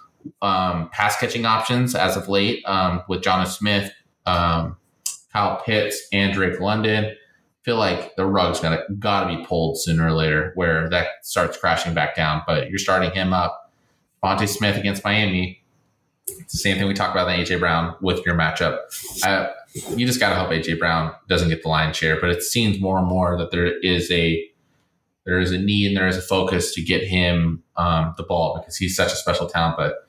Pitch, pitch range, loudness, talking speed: 90 Hz, 85-100 Hz, -21 LUFS, 205 wpm